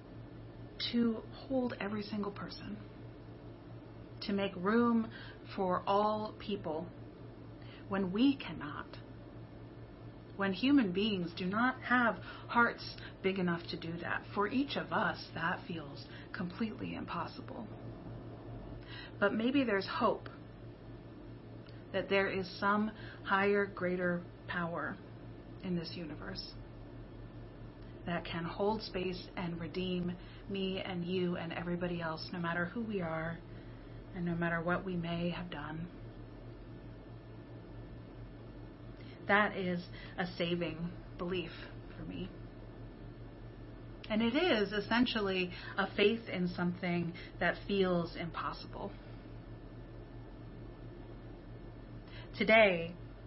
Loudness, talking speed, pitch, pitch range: -35 LUFS, 105 wpm, 190 Hz, 175-210 Hz